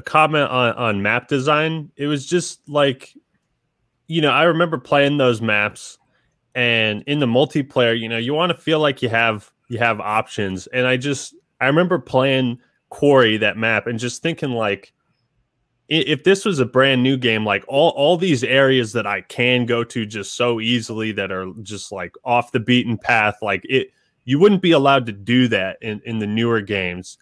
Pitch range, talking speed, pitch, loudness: 115-145 Hz, 195 wpm, 125 Hz, -18 LUFS